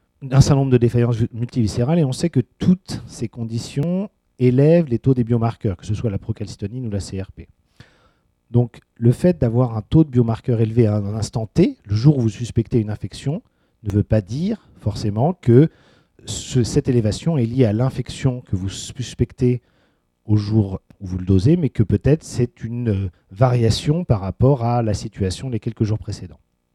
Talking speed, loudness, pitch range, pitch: 185 wpm, -20 LUFS, 105-130 Hz, 120 Hz